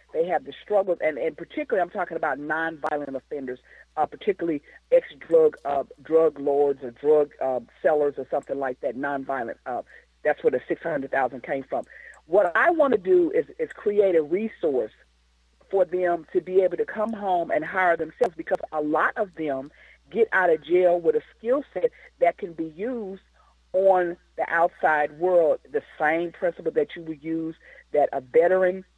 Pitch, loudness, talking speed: 180 Hz, -25 LUFS, 180 wpm